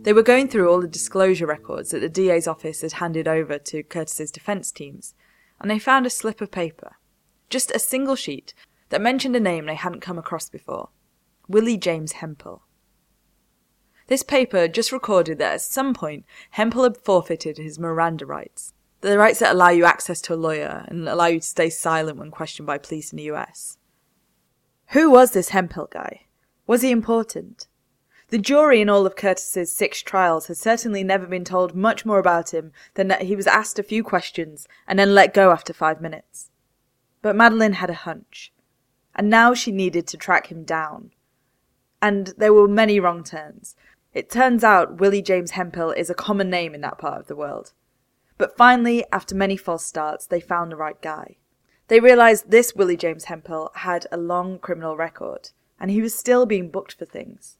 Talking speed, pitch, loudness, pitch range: 190 wpm, 185 Hz, -19 LUFS, 165-220 Hz